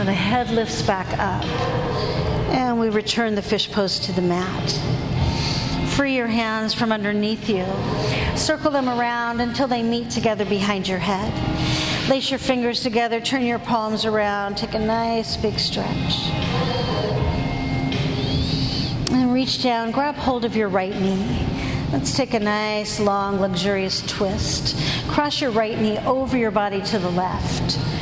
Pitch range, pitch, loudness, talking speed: 200-240 Hz, 220 Hz, -22 LUFS, 150 wpm